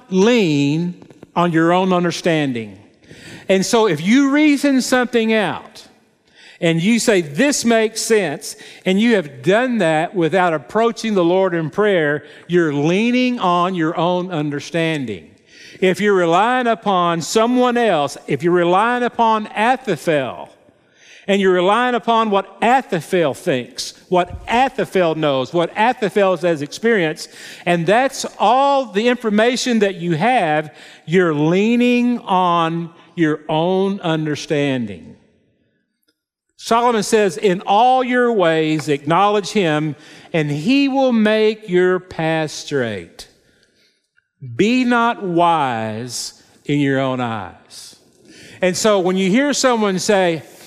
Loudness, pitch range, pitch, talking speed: -17 LUFS, 160-225 Hz, 185 Hz, 120 wpm